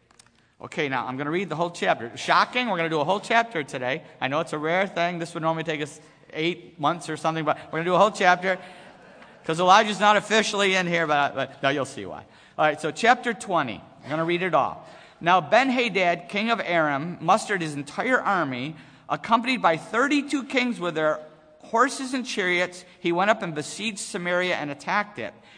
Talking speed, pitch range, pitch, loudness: 215 wpm, 155-210 Hz, 175 Hz, -24 LUFS